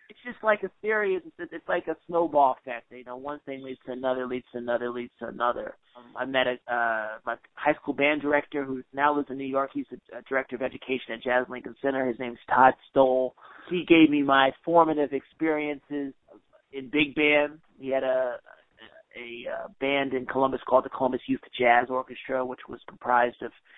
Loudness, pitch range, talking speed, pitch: -26 LUFS, 125-150 Hz, 200 wpm, 135 Hz